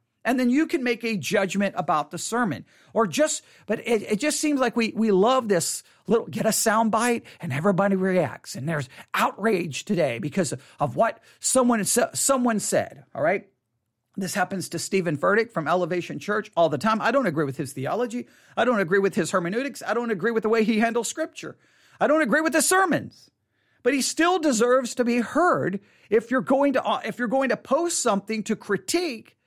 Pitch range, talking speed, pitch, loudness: 185-245 Hz, 205 wpm, 220 Hz, -24 LUFS